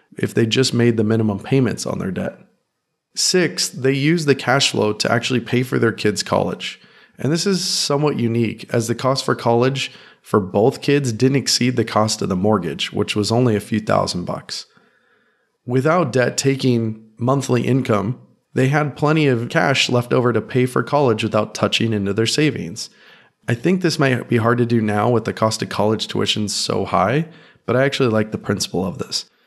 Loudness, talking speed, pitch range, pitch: -18 LUFS, 195 wpm, 110-135 Hz, 125 Hz